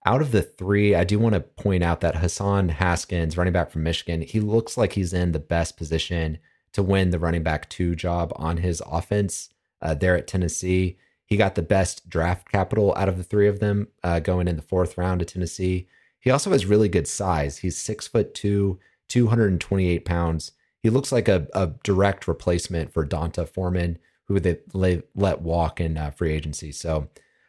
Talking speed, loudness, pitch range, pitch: 200 wpm, -24 LUFS, 85-100 Hz, 90 Hz